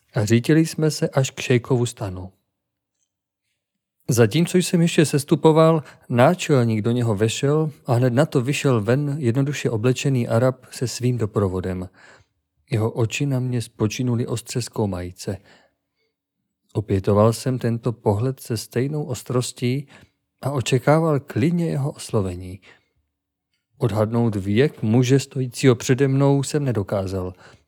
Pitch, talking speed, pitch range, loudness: 125 Hz, 120 wpm, 110-140 Hz, -21 LUFS